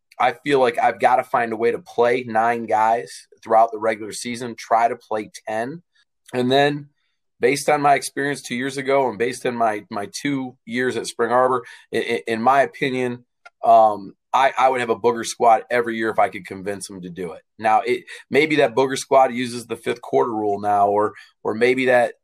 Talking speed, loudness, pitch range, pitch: 210 wpm, -20 LUFS, 110-135 Hz, 120 Hz